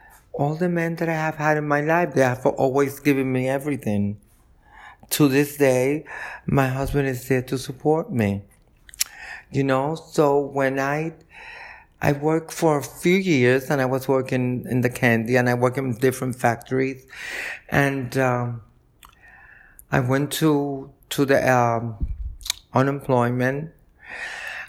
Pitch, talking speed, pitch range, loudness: 135 Hz, 145 wpm, 125-150 Hz, -22 LUFS